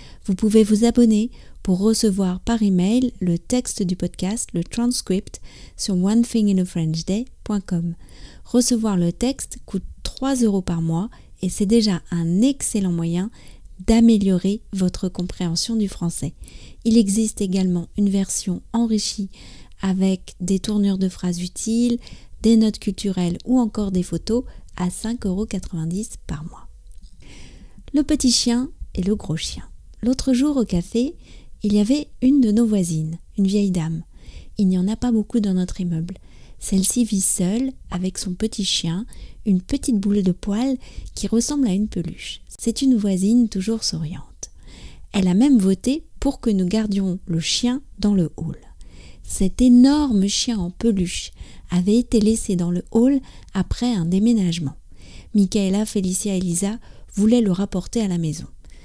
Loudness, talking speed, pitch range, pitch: -20 LUFS, 150 wpm, 180-230 Hz, 200 Hz